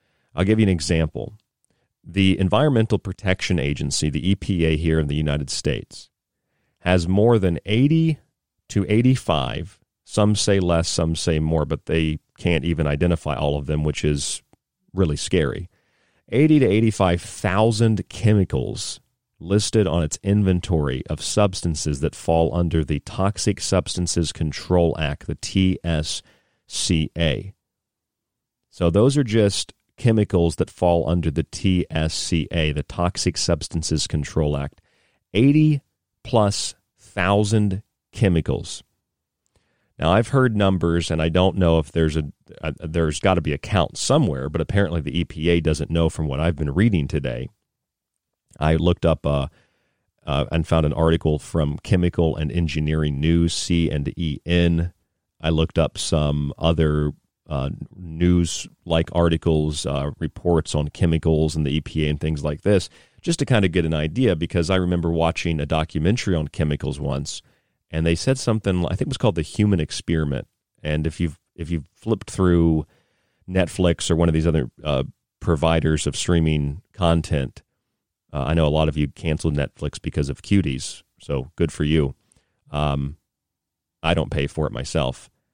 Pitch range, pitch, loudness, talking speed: 80-95 Hz, 85 Hz, -22 LUFS, 150 wpm